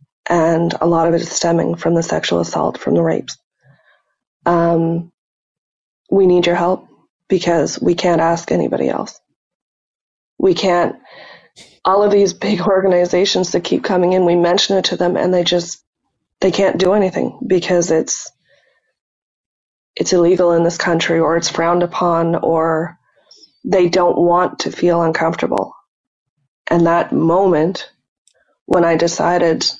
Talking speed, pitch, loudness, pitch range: 145 wpm, 175 Hz, -15 LUFS, 165-185 Hz